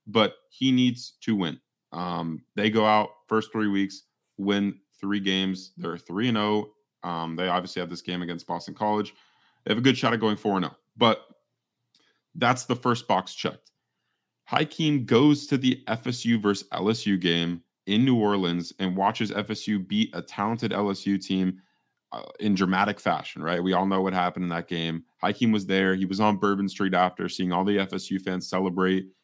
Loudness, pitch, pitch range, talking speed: -26 LUFS, 100 Hz, 90-110 Hz, 185 wpm